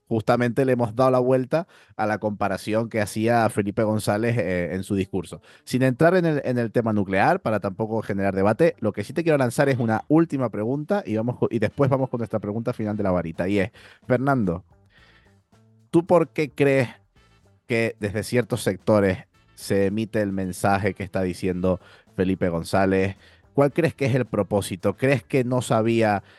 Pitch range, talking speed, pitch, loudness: 100-125 Hz, 185 wpm, 110 Hz, -23 LUFS